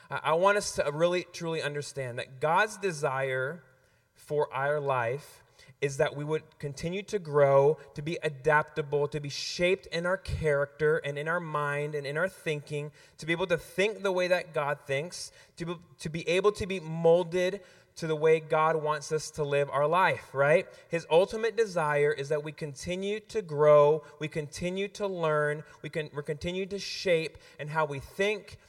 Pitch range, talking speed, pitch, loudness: 145-175 Hz, 180 wpm, 155 Hz, -29 LUFS